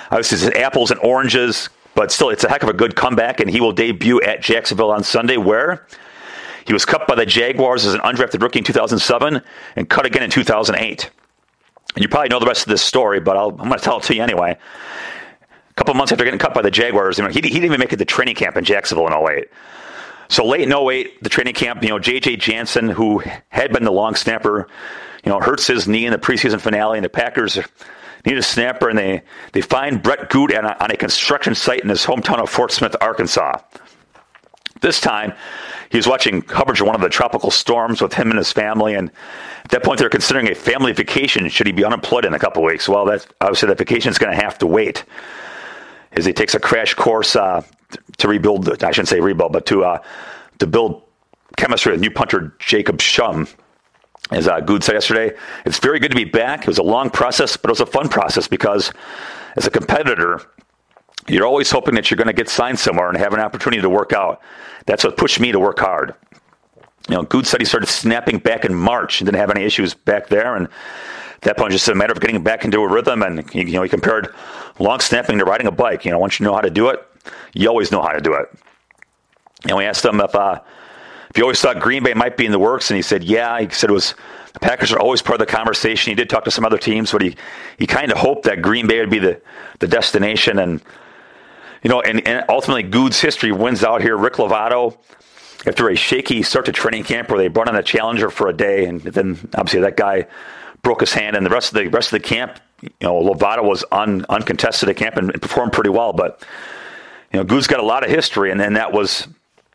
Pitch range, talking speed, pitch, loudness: 100-125 Hz, 235 wpm, 110 Hz, -16 LUFS